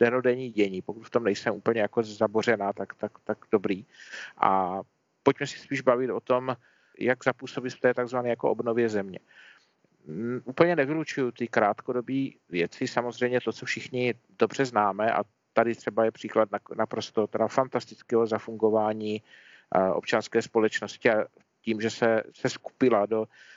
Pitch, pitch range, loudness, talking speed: 120 Hz, 110-130 Hz, -28 LUFS, 155 wpm